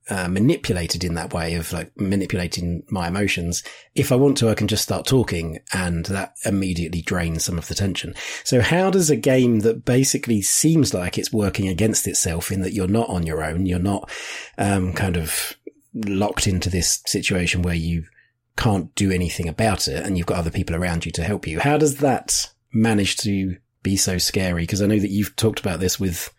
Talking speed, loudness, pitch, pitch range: 205 wpm, -21 LUFS, 95 Hz, 85-110 Hz